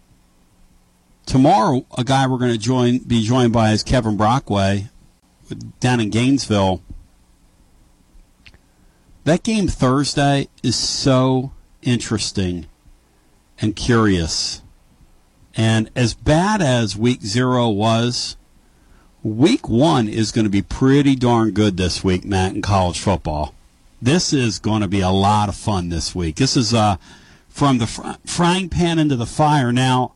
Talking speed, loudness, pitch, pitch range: 135 wpm, -18 LUFS, 110 Hz, 95-130 Hz